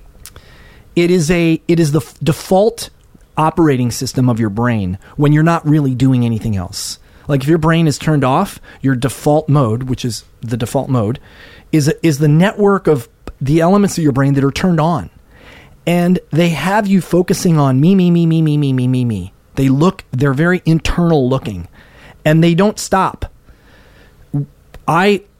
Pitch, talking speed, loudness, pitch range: 150 Hz, 175 wpm, -14 LUFS, 130-170 Hz